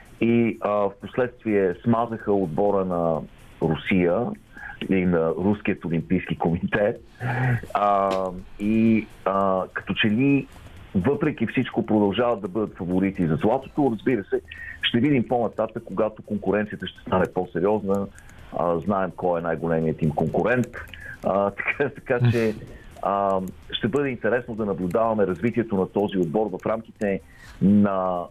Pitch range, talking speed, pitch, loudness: 95-115 Hz, 125 wpm, 100 Hz, -24 LUFS